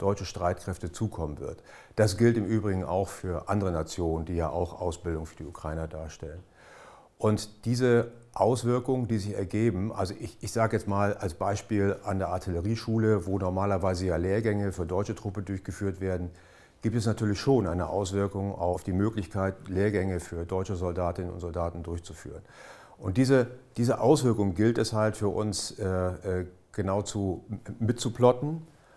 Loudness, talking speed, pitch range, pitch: -29 LUFS, 155 wpm, 90-110 Hz, 100 Hz